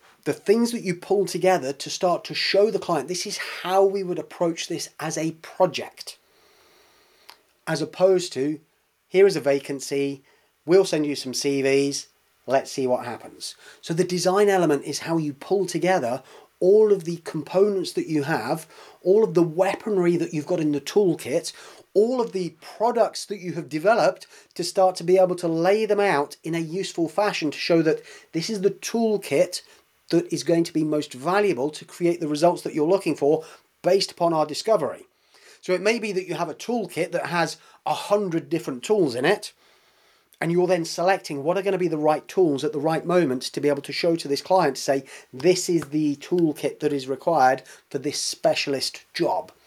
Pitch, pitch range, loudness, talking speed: 175 Hz, 150-195 Hz, -23 LUFS, 195 wpm